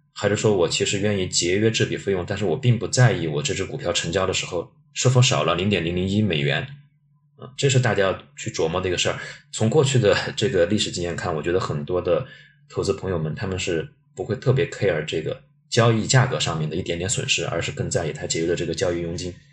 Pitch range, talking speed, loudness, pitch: 90-135 Hz, 365 characters per minute, -22 LUFS, 110 Hz